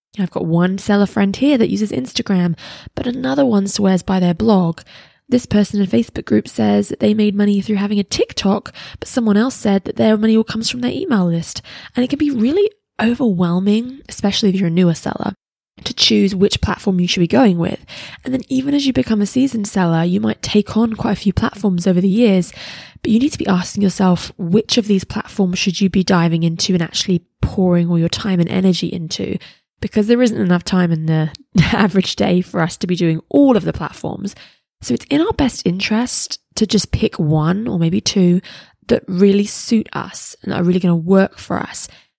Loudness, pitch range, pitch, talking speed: -16 LUFS, 180-220 Hz, 200 Hz, 220 wpm